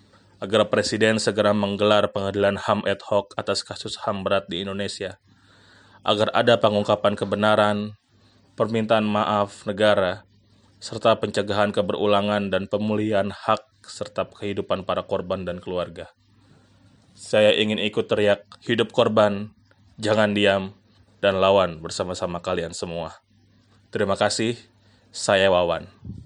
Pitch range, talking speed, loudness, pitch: 100-110 Hz, 115 wpm, -22 LUFS, 105 Hz